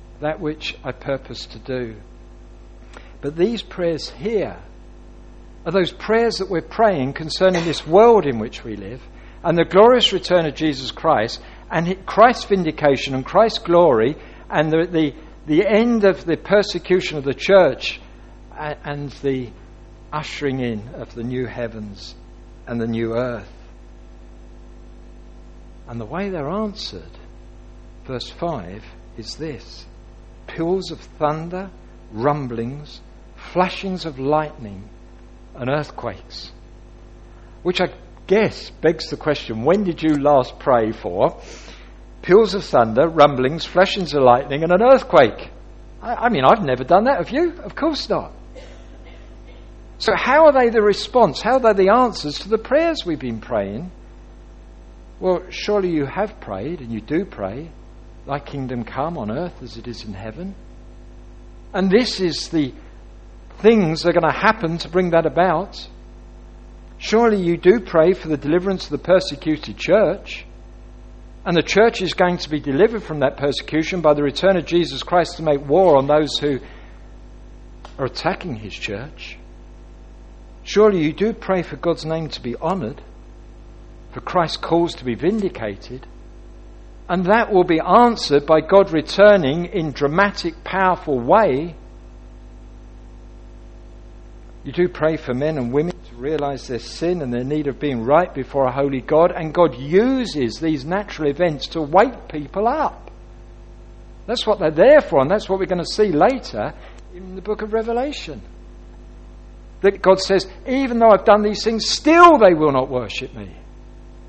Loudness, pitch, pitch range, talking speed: -18 LUFS, 150 Hz, 115-185 Hz, 155 wpm